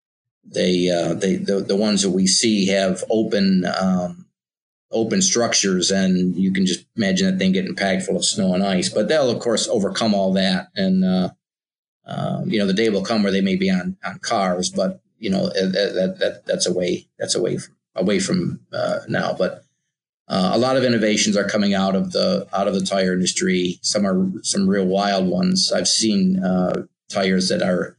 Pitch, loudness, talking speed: 100 Hz, -20 LUFS, 205 wpm